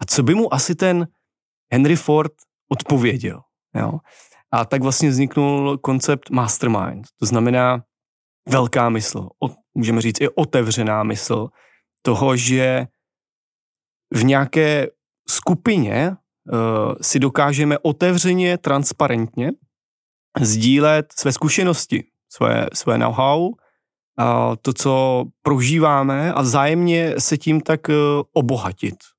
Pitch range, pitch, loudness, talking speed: 125-155 Hz, 140 Hz, -18 LUFS, 105 wpm